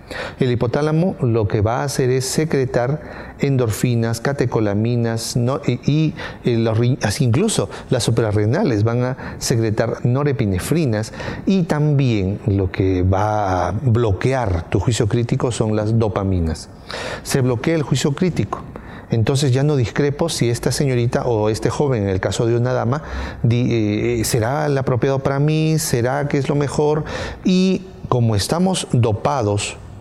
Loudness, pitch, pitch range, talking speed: -19 LUFS, 125 Hz, 110-145 Hz, 145 wpm